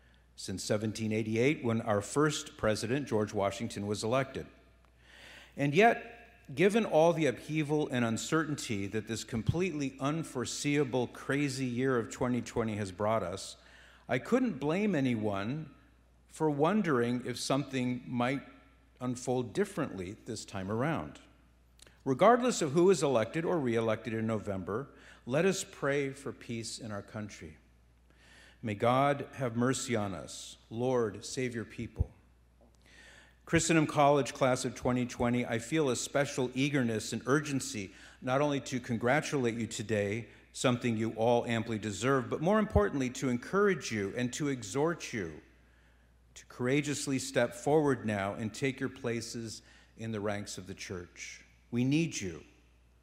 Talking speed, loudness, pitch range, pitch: 135 wpm, -32 LUFS, 105-140 Hz, 120 Hz